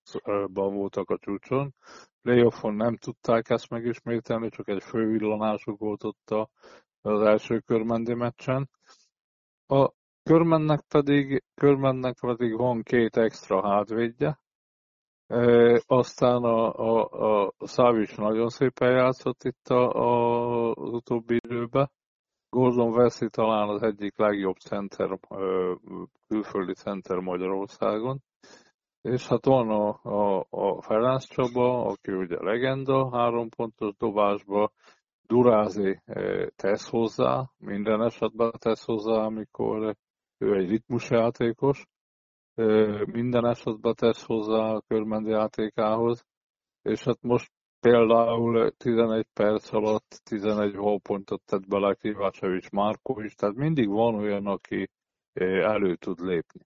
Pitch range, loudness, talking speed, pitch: 105-125 Hz, -26 LUFS, 115 wpm, 115 Hz